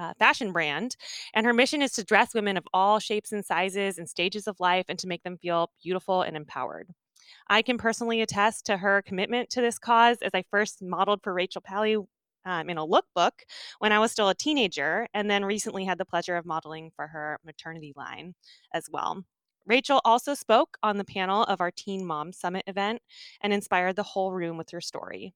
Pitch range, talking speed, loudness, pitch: 180-220 Hz, 205 wpm, -27 LUFS, 200 Hz